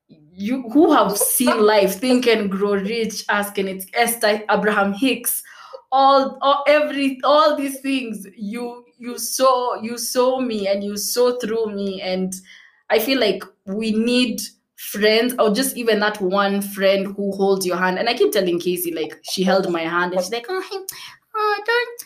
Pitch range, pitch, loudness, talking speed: 200-260 Hz, 220 Hz, -19 LUFS, 175 wpm